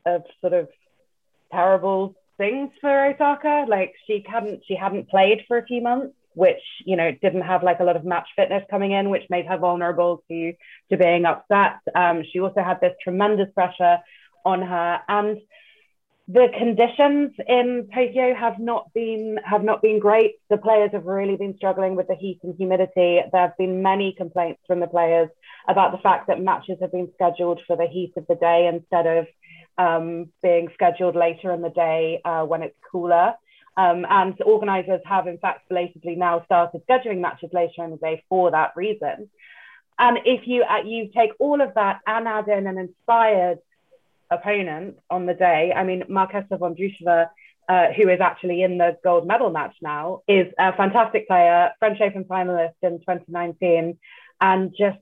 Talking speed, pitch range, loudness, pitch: 185 wpm, 175-210 Hz, -21 LUFS, 185 Hz